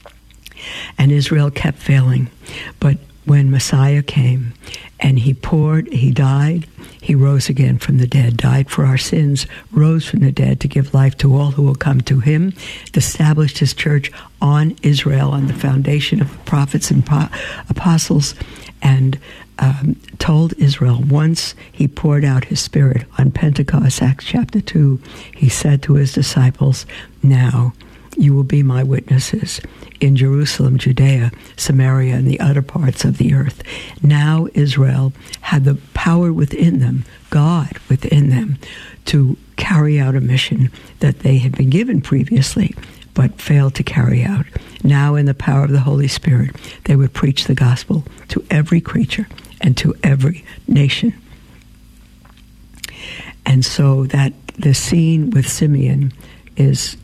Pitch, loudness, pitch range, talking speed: 140 Hz, -15 LUFS, 130-150 Hz, 150 wpm